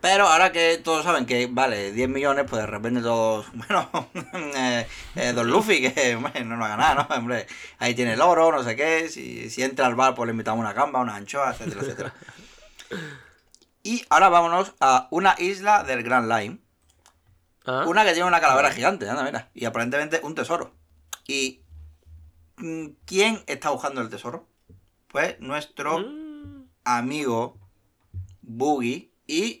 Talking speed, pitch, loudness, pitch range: 165 wpm, 125 Hz, -23 LUFS, 105-160 Hz